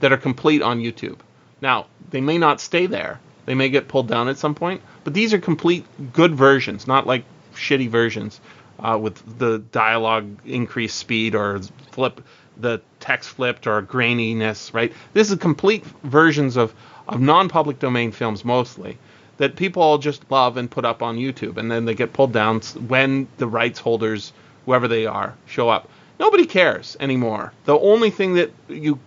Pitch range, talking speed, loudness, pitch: 115-150 Hz, 185 wpm, -20 LUFS, 125 Hz